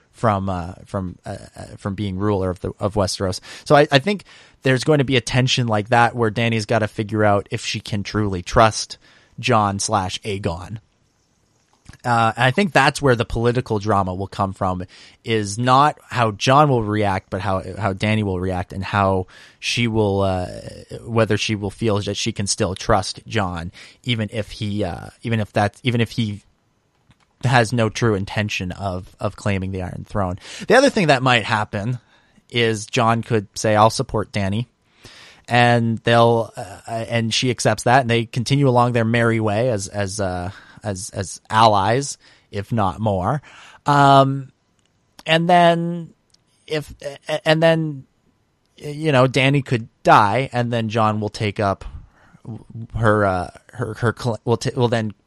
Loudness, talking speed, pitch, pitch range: -19 LUFS, 170 wpm, 110 Hz, 100-120 Hz